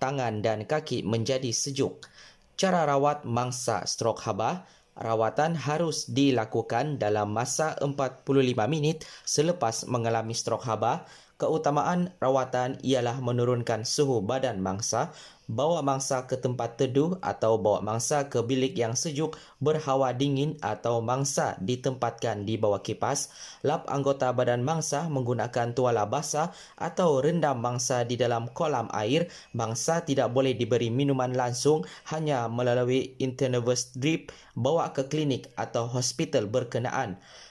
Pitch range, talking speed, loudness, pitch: 115-140 Hz, 125 wpm, -28 LUFS, 130 Hz